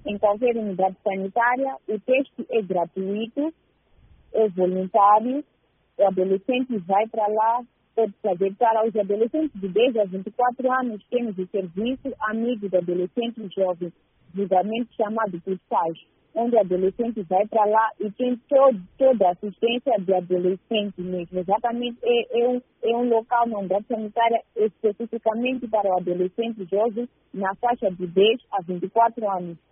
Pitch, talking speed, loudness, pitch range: 215 Hz, 150 wpm, -23 LUFS, 190-235 Hz